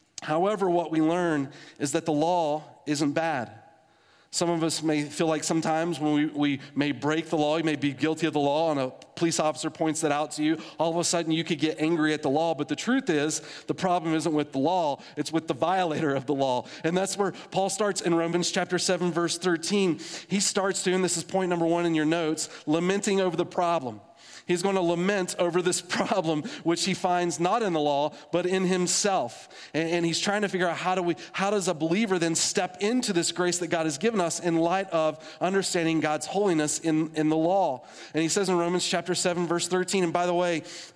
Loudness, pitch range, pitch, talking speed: -26 LUFS, 155-180 Hz, 170 Hz, 230 wpm